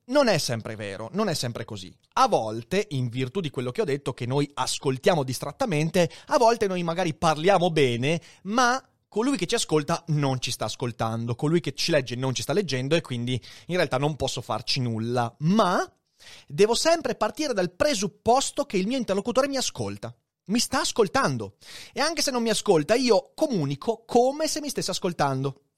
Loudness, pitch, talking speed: -25 LUFS, 160 Hz, 185 wpm